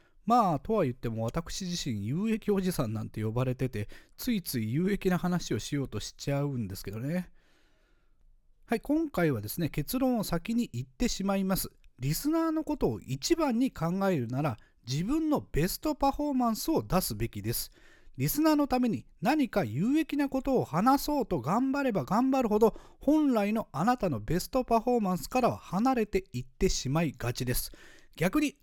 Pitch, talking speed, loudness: 190 Hz, 355 characters per minute, -30 LUFS